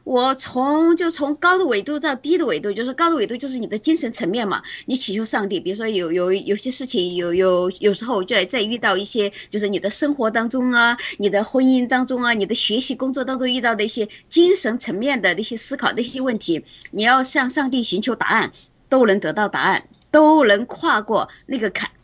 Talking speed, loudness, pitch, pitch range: 325 characters per minute, -19 LUFS, 240 Hz, 205-265 Hz